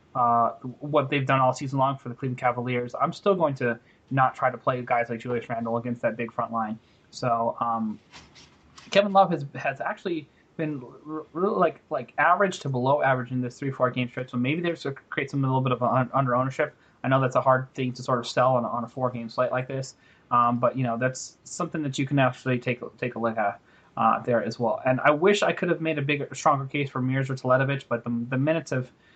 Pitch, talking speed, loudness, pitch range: 130 Hz, 250 wpm, -26 LUFS, 120-145 Hz